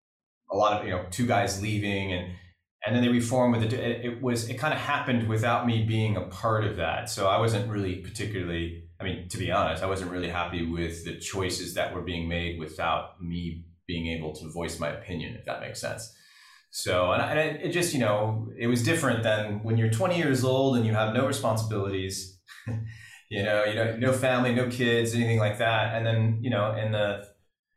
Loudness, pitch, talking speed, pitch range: -28 LUFS, 105 Hz, 215 wpm, 90-120 Hz